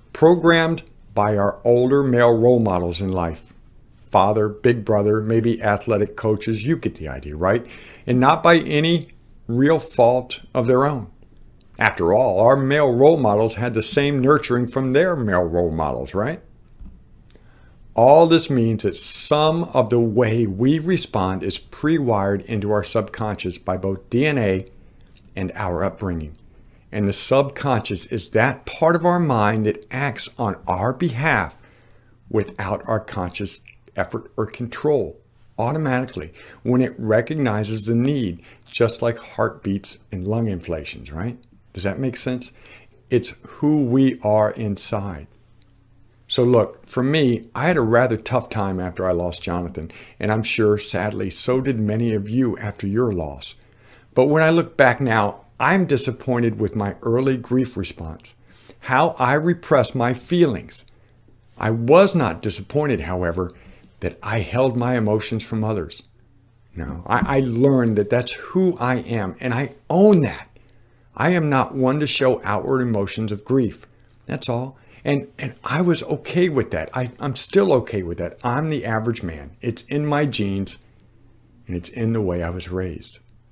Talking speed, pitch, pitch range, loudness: 155 wpm, 115 Hz, 100-130 Hz, -20 LUFS